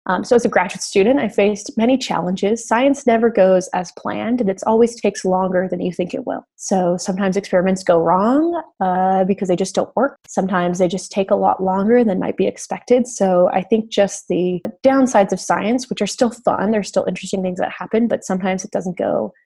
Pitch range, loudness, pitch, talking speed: 185-230 Hz, -18 LUFS, 195 Hz, 215 wpm